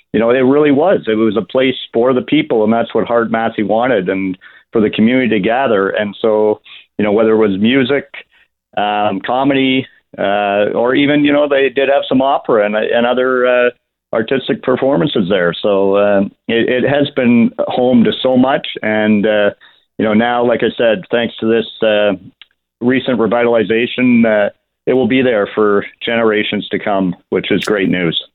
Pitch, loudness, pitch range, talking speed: 115 Hz, -13 LUFS, 105-130 Hz, 185 wpm